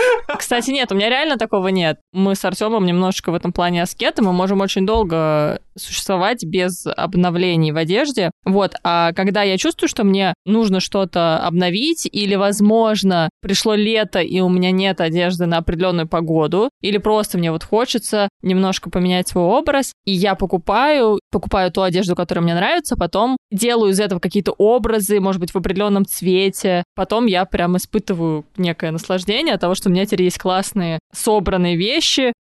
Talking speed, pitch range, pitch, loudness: 170 wpm, 180-215 Hz, 190 Hz, -17 LUFS